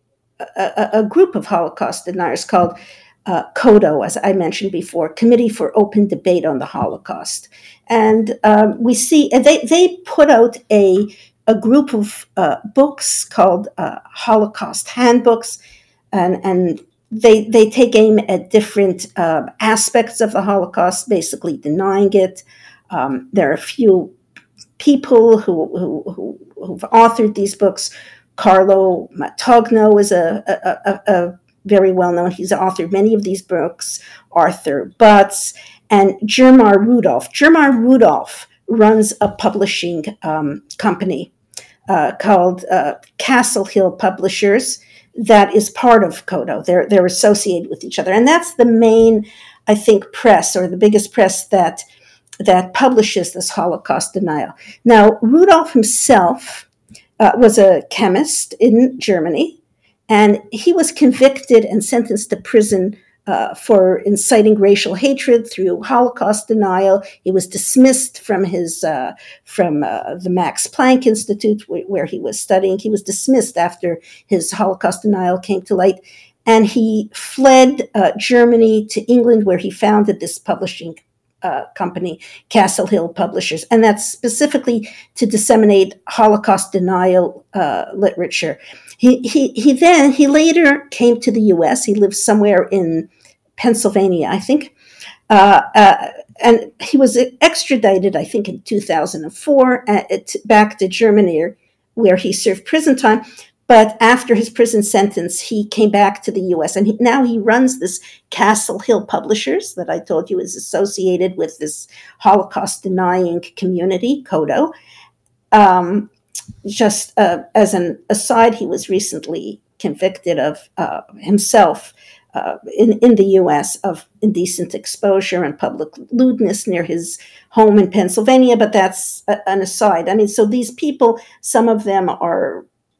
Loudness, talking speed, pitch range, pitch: -14 LUFS, 145 wpm, 190-235 Hz, 210 Hz